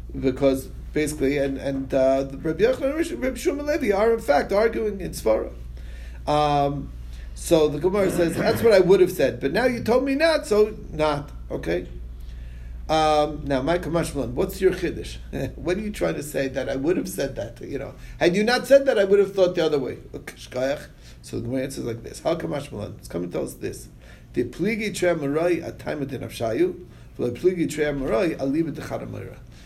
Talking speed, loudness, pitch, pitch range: 175 wpm, -23 LUFS, 150 Hz, 125-200 Hz